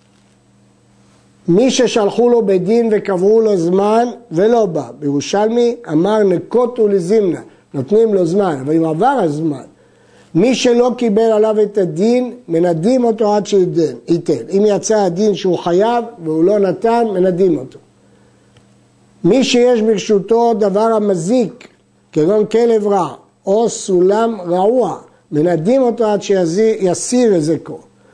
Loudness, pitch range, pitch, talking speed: -14 LUFS, 180-230 Hz, 210 Hz, 125 wpm